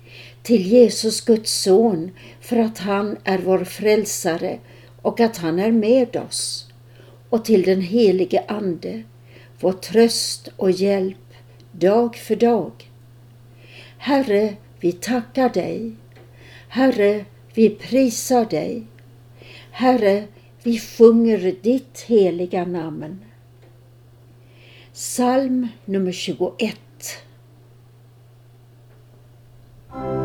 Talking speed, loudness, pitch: 90 wpm, -19 LUFS, 175 Hz